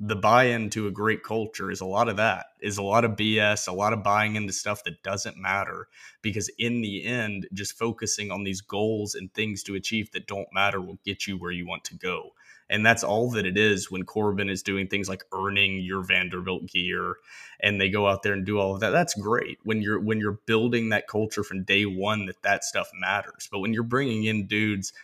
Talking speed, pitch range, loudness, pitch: 235 wpm, 95-110 Hz, -26 LUFS, 105 Hz